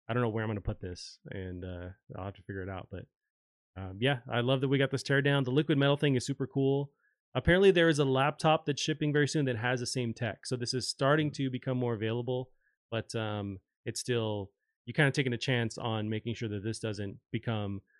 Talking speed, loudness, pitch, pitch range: 245 wpm, -31 LUFS, 125 Hz, 110-140 Hz